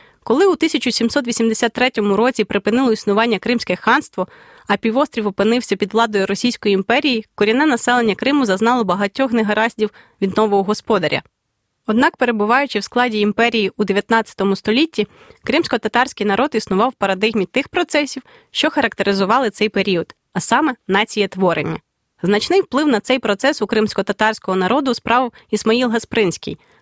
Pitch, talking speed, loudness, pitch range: 225 Hz, 130 wpm, -17 LUFS, 205-250 Hz